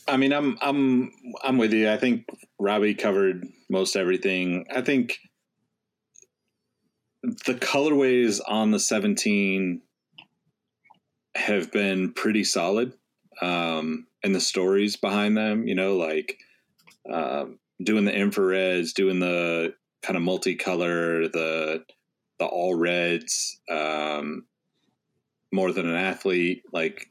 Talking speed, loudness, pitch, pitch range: 115 wpm, -25 LUFS, 95 Hz, 90-125 Hz